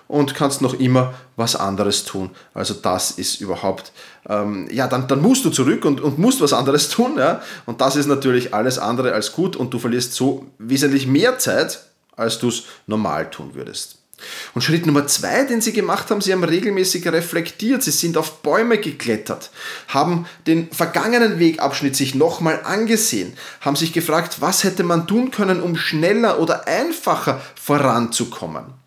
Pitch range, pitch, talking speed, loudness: 125-180 Hz, 145 Hz, 175 wpm, -18 LUFS